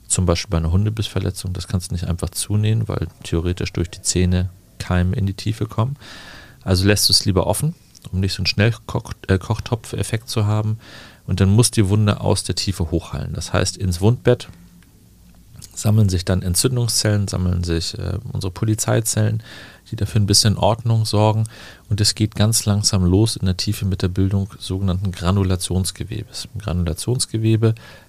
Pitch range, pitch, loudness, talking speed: 95-110 Hz, 100 Hz, -20 LUFS, 170 wpm